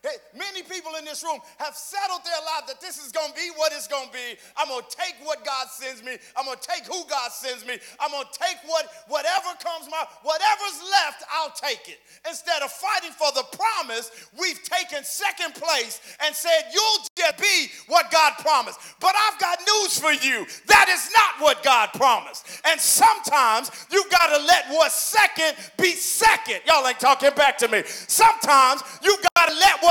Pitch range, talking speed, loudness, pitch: 295-370 Hz, 195 wpm, -21 LUFS, 320 Hz